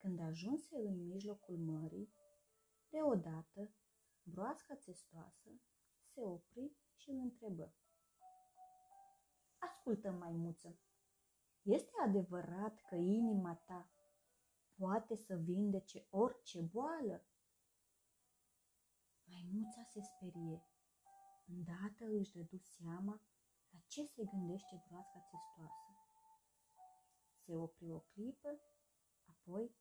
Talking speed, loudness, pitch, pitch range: 85 wpm, -45 LUFS, 195 Hz, 170-240 Hz